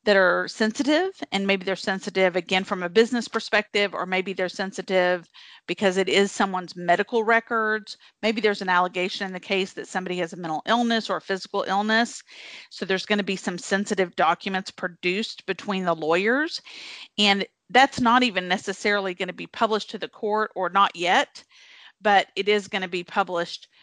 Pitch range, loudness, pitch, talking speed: 185-220 Hz, -24 LUFS, 195 Hz, 185 wpm